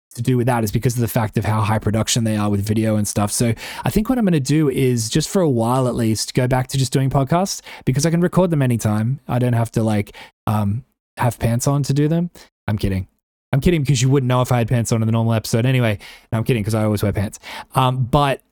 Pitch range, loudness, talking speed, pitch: 110-140 Hz, -19 LUFS, 280 wpm, 120 Hz